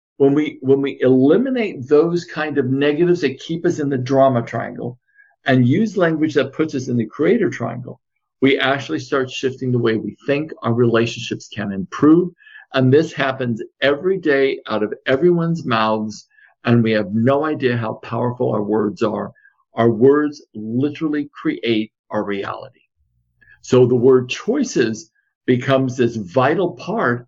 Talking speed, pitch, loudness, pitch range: 155 wpm, 130 Hz, -18 LUFS, 115-150 Hz